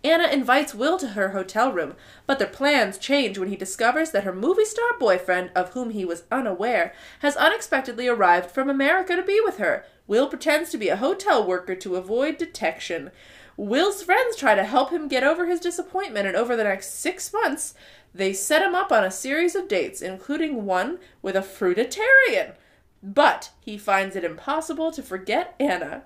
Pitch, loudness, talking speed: 275 Hz, -23 LUFS, 185 wpm